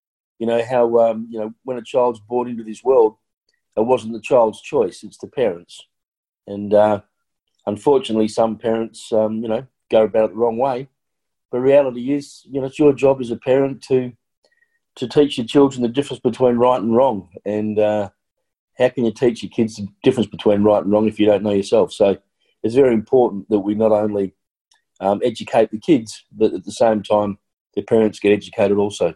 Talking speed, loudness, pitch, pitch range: 200 wpm, -18 LUFS, 115 Hz, 105-125 Hz